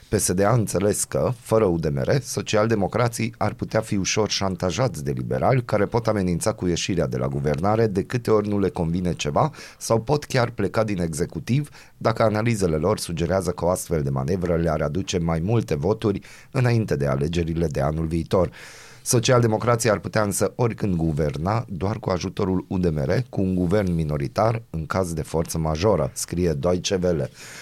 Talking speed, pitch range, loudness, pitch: 165 wpm, 85-110 Hz, -23 LUFS, 95 Hz